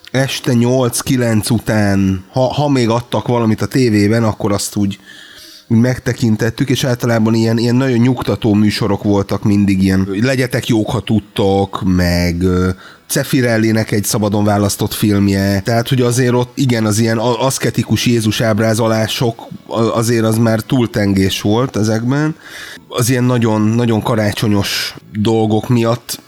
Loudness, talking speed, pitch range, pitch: -14 LUFS, 135 wpm, 105-125 Hz, 115 Hz